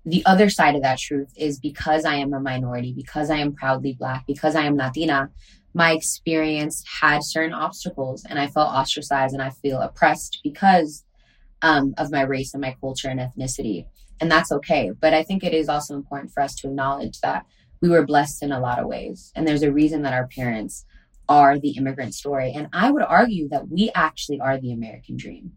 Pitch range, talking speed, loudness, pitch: 135-155 Hz, 210 wpm, -21 LUFS, 145 Hz